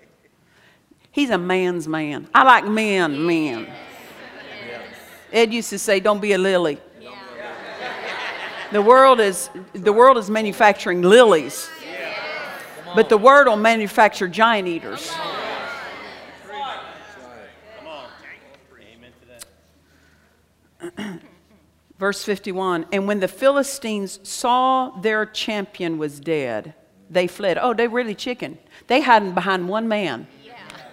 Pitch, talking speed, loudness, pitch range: 205 Hz, 105 wpm, -18 LUFS, 180-230 Hz